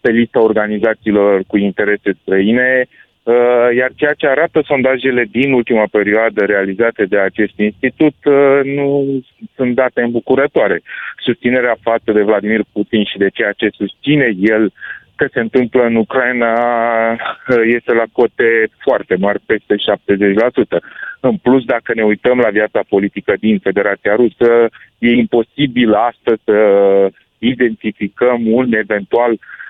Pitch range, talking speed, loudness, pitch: 105-125 Hz, 125 wpm, -13 LUFS, 115 Hz